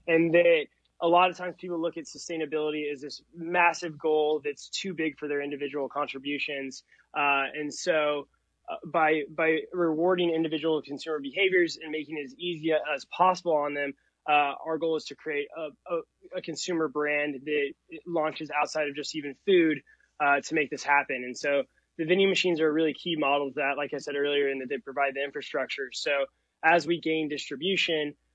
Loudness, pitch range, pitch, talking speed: -28 LUFS, 145-165 Hz, 155 Hz, 190 wpm